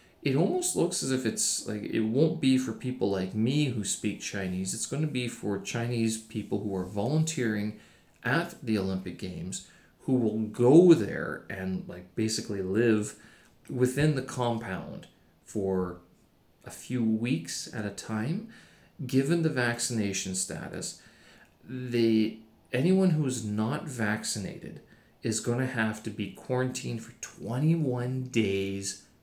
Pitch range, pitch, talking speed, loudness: 105-130 Hz, 115 Hz, 140 wpm, -29 LUFS